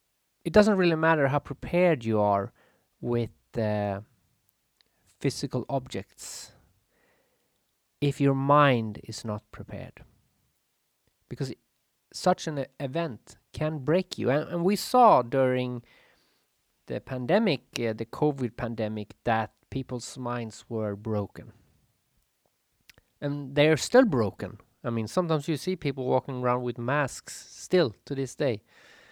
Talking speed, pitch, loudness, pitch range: 130 wpm, 130 Hz, -27 LUFS, 110-150 Hz